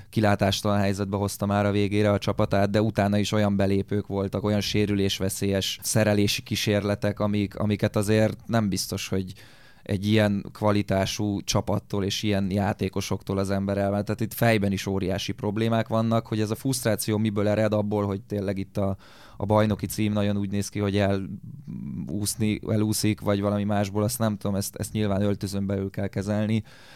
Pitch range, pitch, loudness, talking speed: 100-105 Hz, 105 Hz, -25 LUFS, 165 wpm